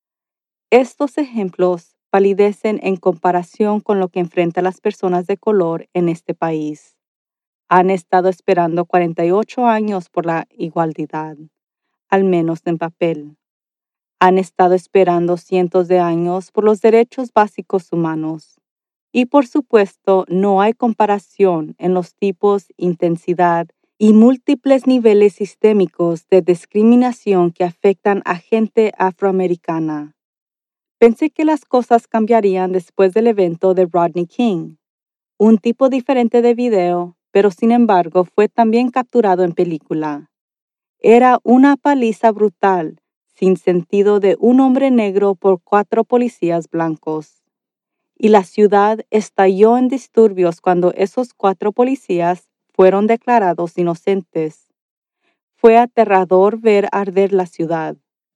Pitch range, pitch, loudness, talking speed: 175-225 Hz, 195 Hz, -15 LUFS, 120 wpm